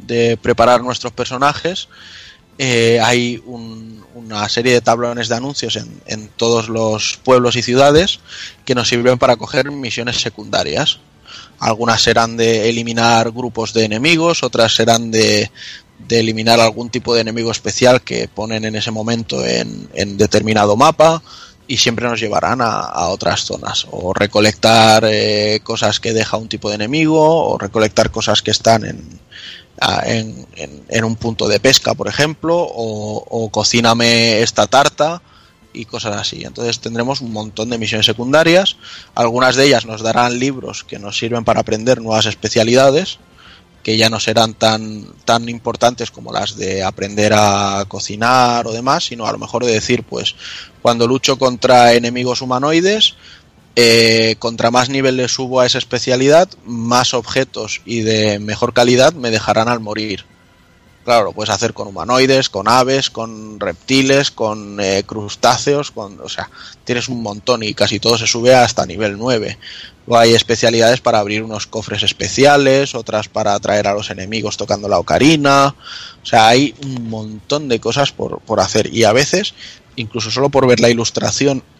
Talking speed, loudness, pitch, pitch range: 165 wpm, -14 LUFS, 115 Hz, 110-125 Hz